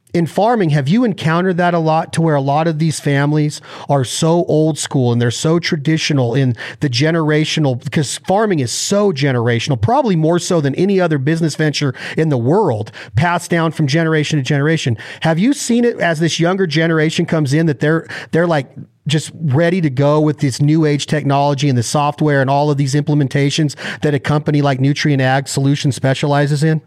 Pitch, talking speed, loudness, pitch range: 150 Hz, 195 wpm, -15 LUFS, 140-165 Hz